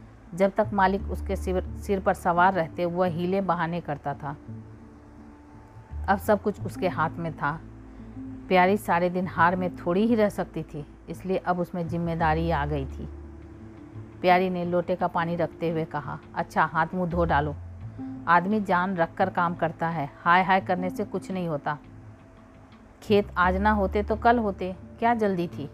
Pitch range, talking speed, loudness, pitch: 130-185 Hz, 175 wpm, -26 LUFS, 170 Hz